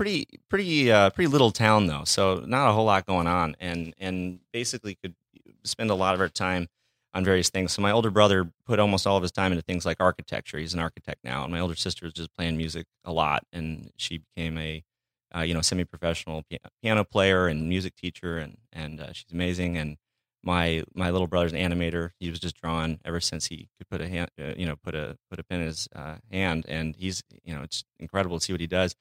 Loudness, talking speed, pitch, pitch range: -27 LUFS, 240 wpm, 90 Hz, 80-95 Hz